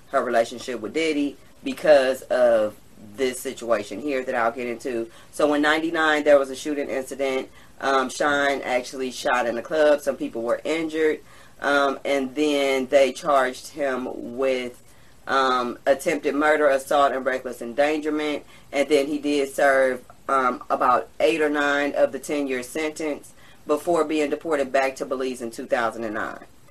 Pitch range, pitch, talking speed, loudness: 130-150 Hz, 140 Hz, 155 wpm, -23 LUFS